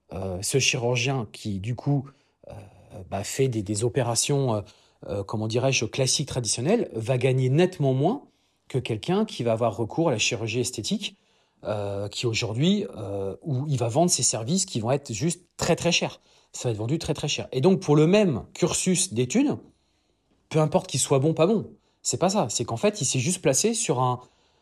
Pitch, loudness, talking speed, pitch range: 130 Hz, -25 LUFS, 200 wpm, 115-165 Hz